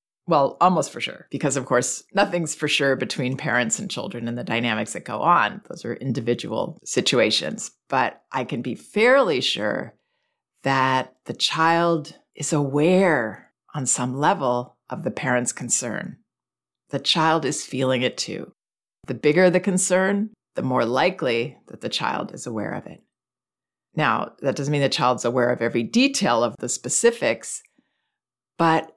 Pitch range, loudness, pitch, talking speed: 125-170 Hz, -22 LUFS, 140 Hz, 155 wpm